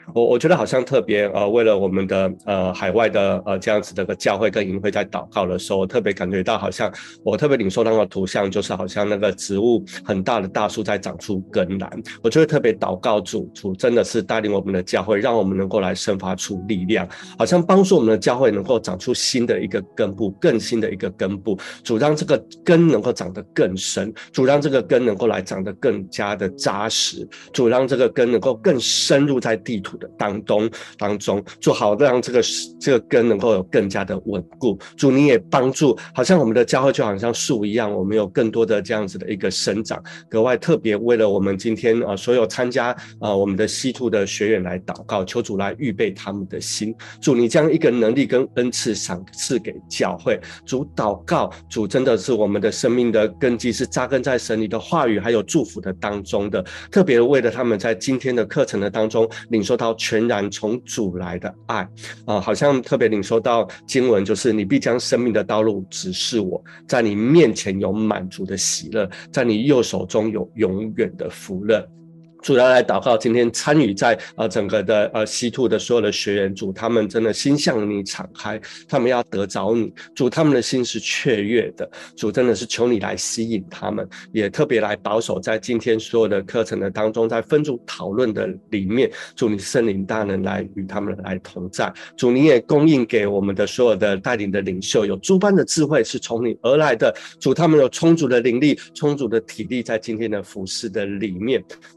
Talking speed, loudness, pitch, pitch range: 305 characters per minute, -20 LUFS, 110 Hz, 100-125 Hz